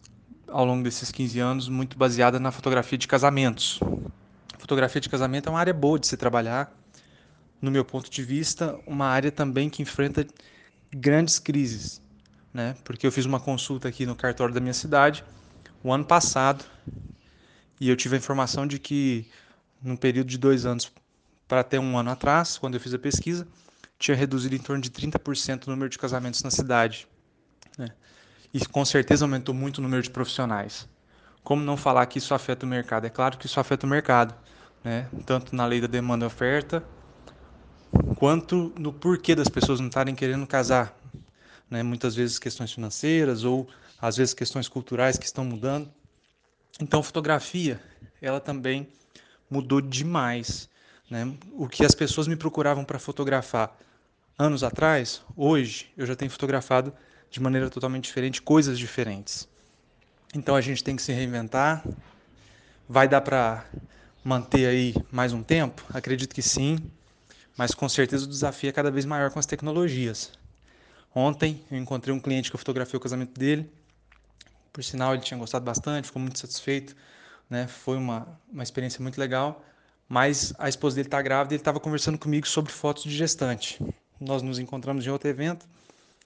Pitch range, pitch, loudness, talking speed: 125-145 Hz, 130 Hz, -26 LUFS, 170 wpm